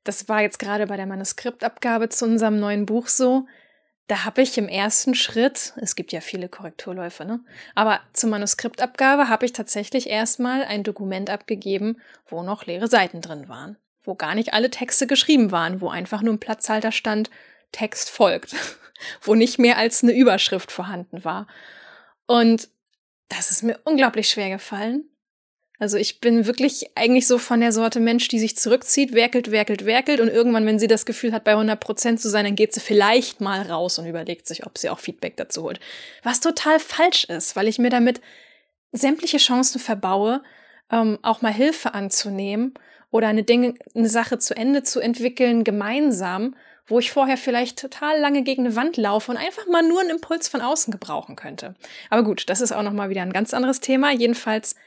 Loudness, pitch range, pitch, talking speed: -20 LUFS, 210-255 Hz, 230 Hz, 190 wpm